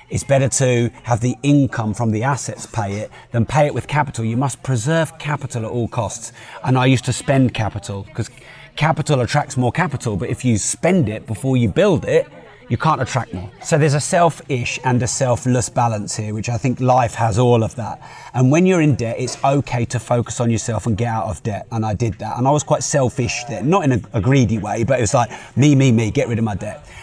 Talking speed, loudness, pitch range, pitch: 240 wpm, -18 LUFS, 115-140 Hz, 125 Hz